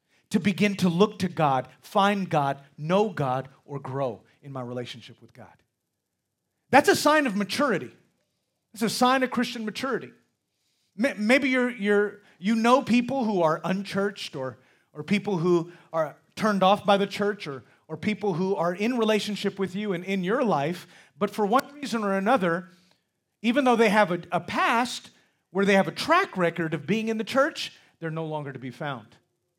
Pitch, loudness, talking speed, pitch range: 200 Hz, -25 LUFS, 185 wpm, 160-225 Hz